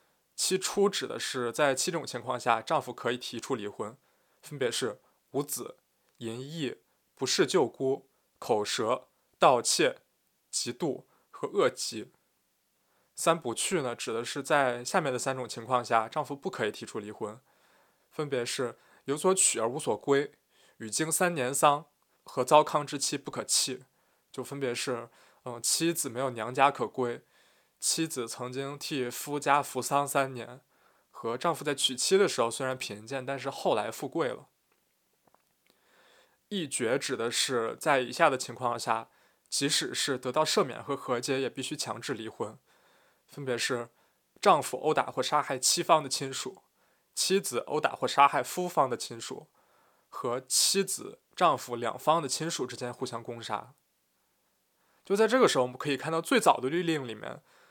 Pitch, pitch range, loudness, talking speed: 135 Hz, 125-155 Hz, -29 LUFS, 230 characters per minute